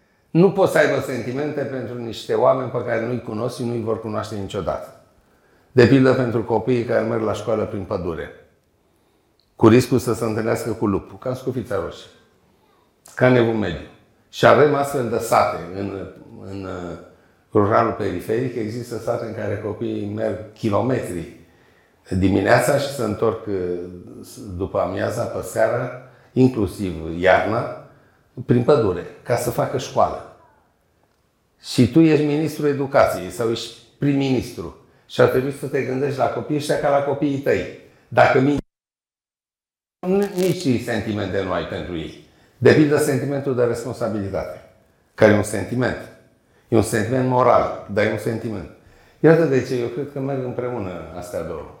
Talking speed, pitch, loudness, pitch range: 150 wpm, 120 Hz, -20 LUFS, 105-130 Hz